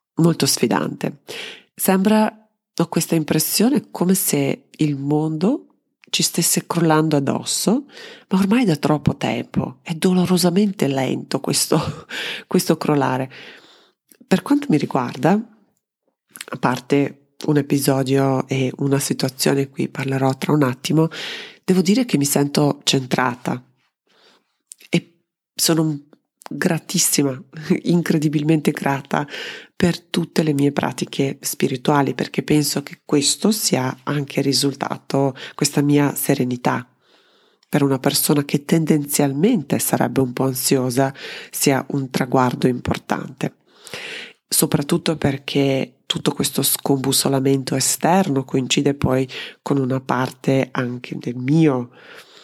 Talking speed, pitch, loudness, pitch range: 110 wpm, 150 Hz, -19 LUFS, 135-180 Hz